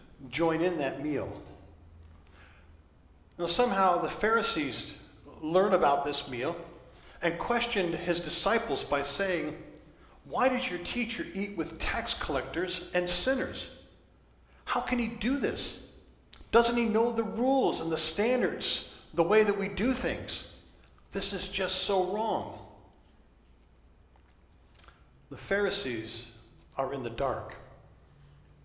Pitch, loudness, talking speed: 160 Hz, -30 LUFS, 120 wpm